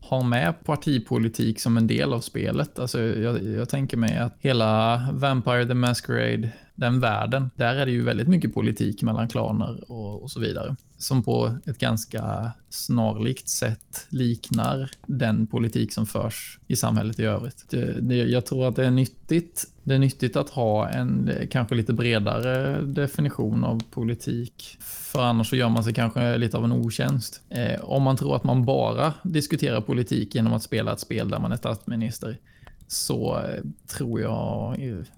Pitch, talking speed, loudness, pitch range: 120 Hz, 170 wpm, -25 LUFS, 115-130 Hz